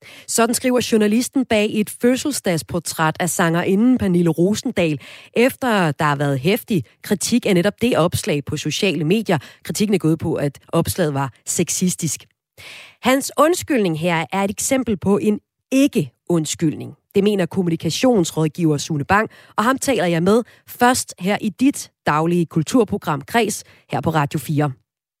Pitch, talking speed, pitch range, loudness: 185 Hz, 145 wpm, 155-220 Hz, -19 LUFS